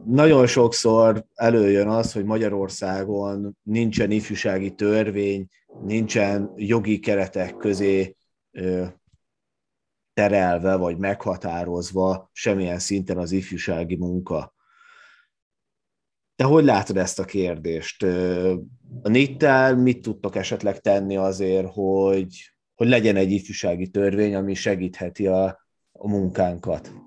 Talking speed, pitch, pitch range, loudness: 100 wpm, 100 Hz, 95-105 Hz, -22 LUFS